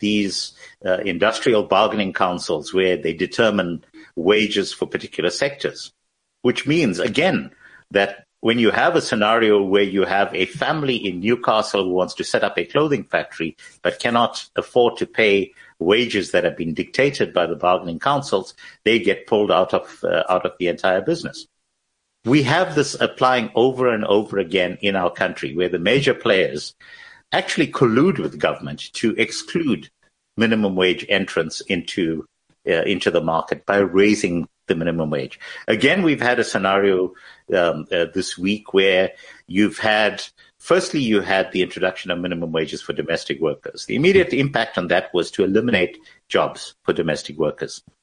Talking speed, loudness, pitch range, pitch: 160 wpm, -20 LUFS, 90-110 Hz, 100 Hz